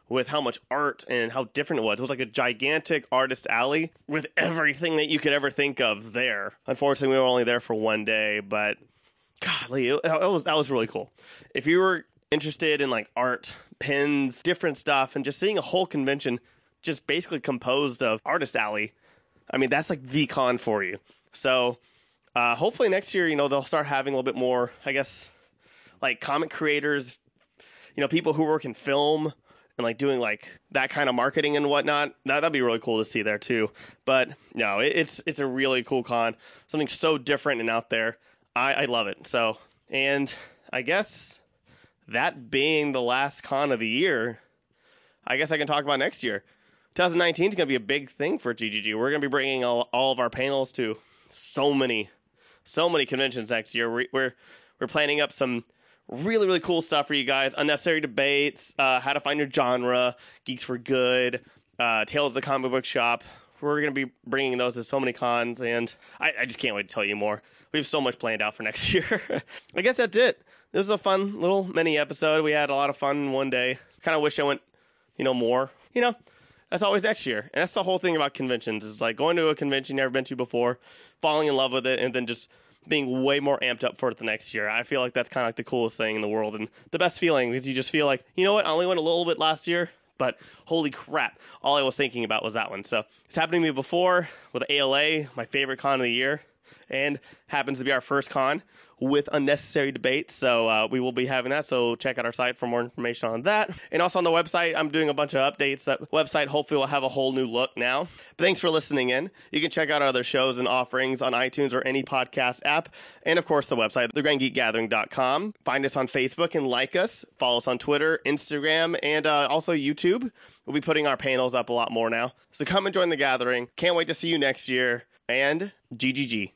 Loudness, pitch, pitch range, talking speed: -25 LUFS, 135 Hz, 125-150 Hz, 230 wpm